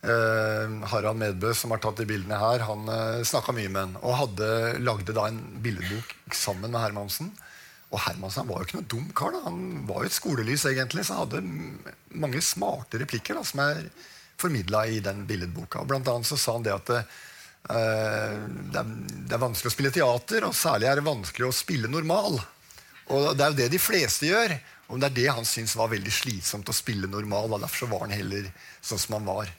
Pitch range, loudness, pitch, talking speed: 105-120 Hz, -27 LUFS, 110 Hz, 215 wpm